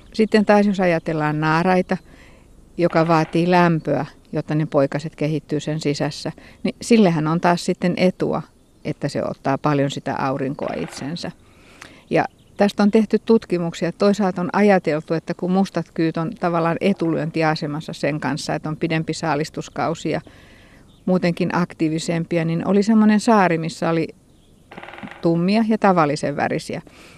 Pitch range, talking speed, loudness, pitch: 155-185 Hz, 135 wpm, -20 LUFS, 165 Hz